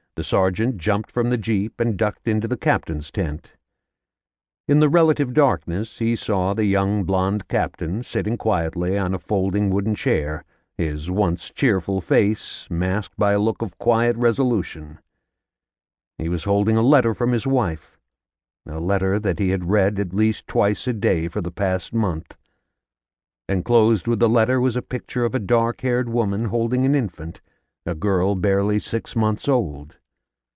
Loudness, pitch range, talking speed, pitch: -22 LUFS, 90-115 Hz, 165 wpm, 100 Hz